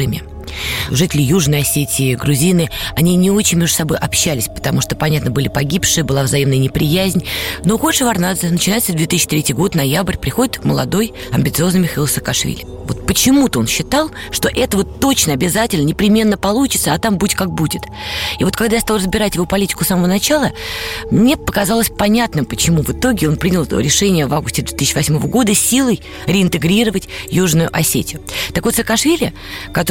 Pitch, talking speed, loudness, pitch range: 175 Hz, 160 wpm, -15 LUFS, 145-205 Hz